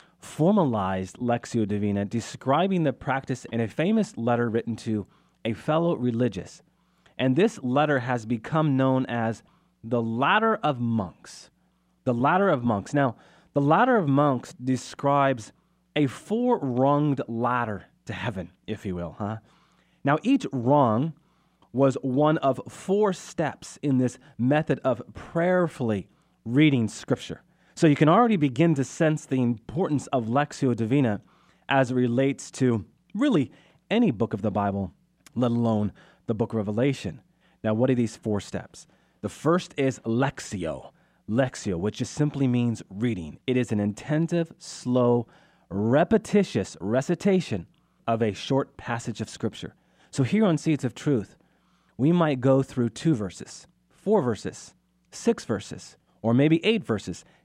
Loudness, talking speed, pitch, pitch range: -25 LUFS, 145 wpm, 130 Hz, 115-155 Hz